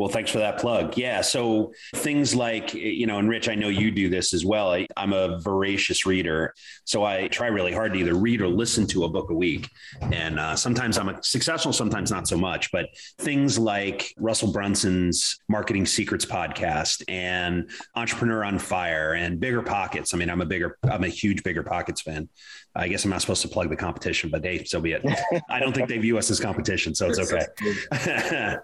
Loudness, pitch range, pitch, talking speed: -25 LUFS, 90-115 Hz, 100 Hz, 210 wpm